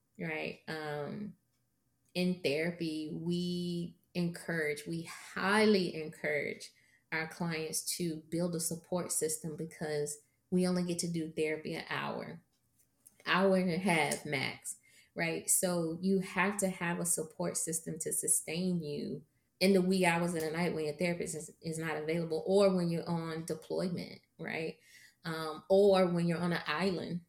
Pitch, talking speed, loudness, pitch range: 170 Hz, 150 wpm, -34 LUFS, 155-180 Hz